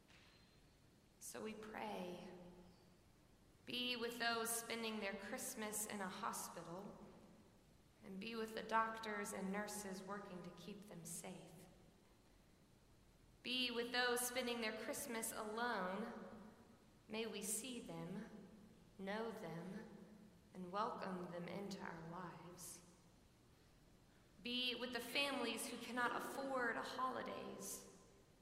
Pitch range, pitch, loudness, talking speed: 185-235 Hz, 210 Hz, -46 LUFS, 110 wpm